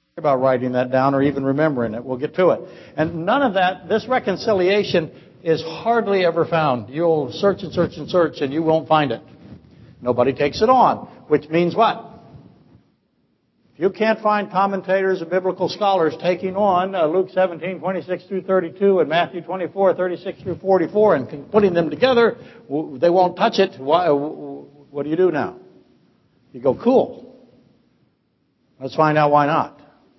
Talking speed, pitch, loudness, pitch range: 165 wpm, 175 Hz, -19 LUFS, 150-190 Hz